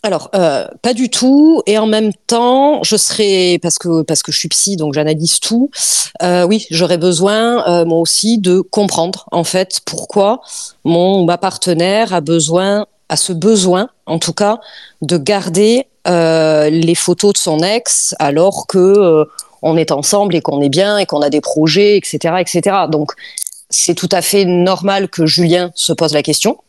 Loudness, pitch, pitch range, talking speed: -12 LUFS, 180 Hz, 165-205 Hz, 180 wpm